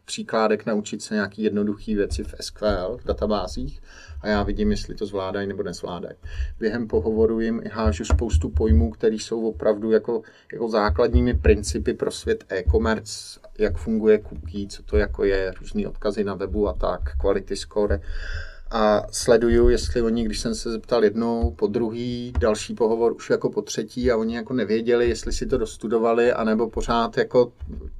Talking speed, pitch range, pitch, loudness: 165 wpm, 95-115 Hz, 105 Hz, -23 LUFS